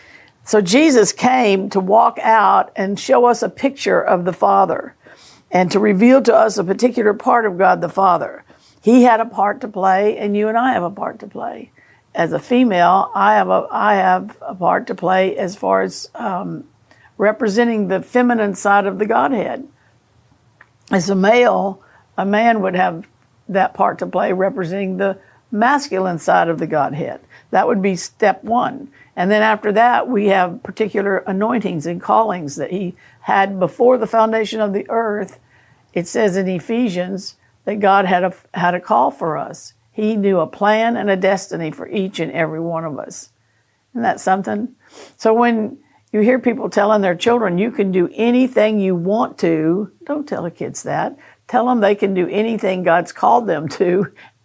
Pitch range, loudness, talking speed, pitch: 185-225 Hz, -16 LUFS, 185 wpm, 200 Hz